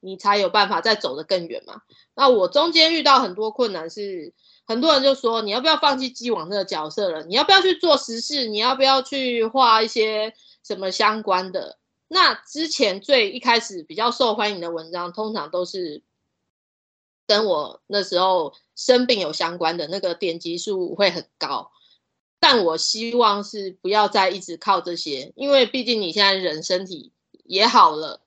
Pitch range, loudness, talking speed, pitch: 185-260 Hz, -20 LUFS, 265 characters per minute, 215 Hz